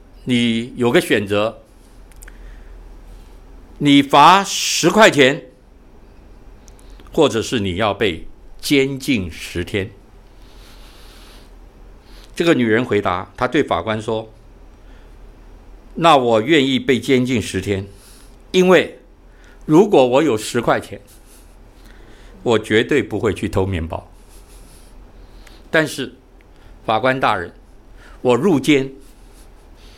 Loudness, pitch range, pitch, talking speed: -16 LUFS, 85-125 Hz, 100 Hz, 135 characters per minute